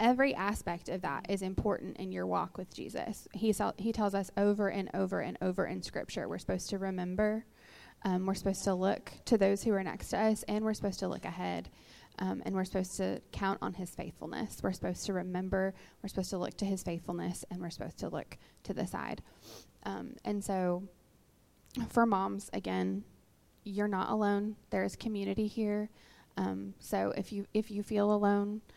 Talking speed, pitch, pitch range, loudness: 195 wpm, 195 Hz, 175-205 Hz, -35 LUFS